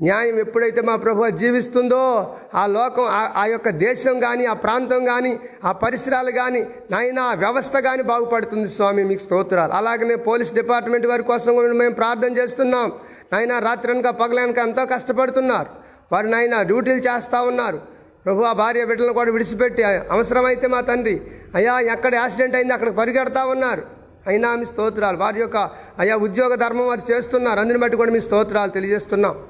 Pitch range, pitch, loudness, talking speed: 225-250 Hz, 240 Hz, -19 LUFS, 155 wpm